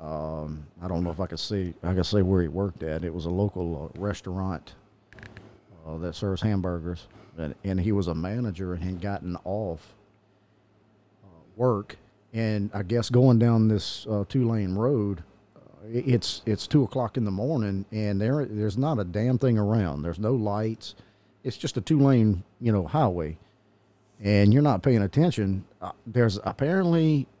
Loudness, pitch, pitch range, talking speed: -26 LUFS, 105 Hz, 95-115 Hz, 175 wpm